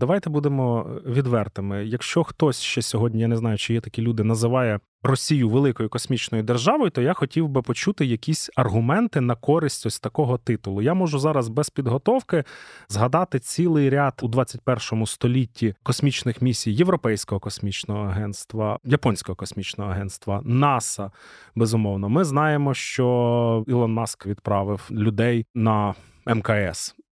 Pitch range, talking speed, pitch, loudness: 110-140 Hz, 135 wpm, 120 Hz, -23 LUFS